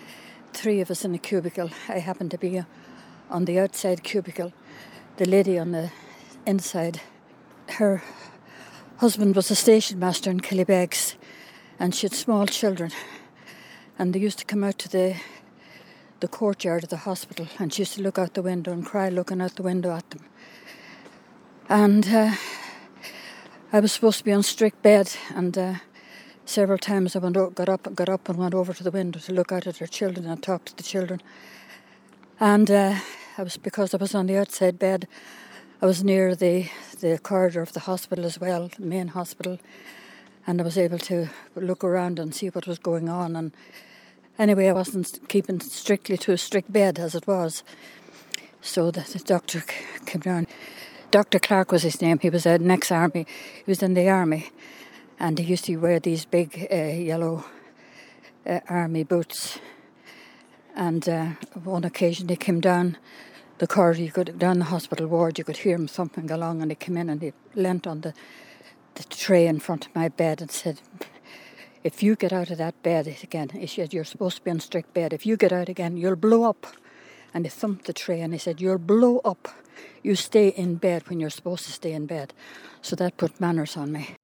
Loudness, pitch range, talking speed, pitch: -24 LUFS, 170-195 Hz, 195 wpm, 180 Hz